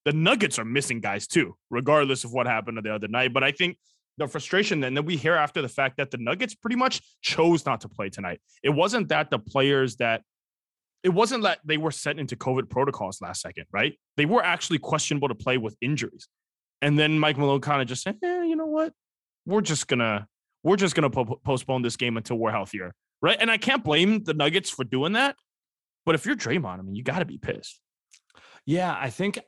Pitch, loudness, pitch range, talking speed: 145 Hz, -25 LUFS, 125-180 Hz, 220 wpm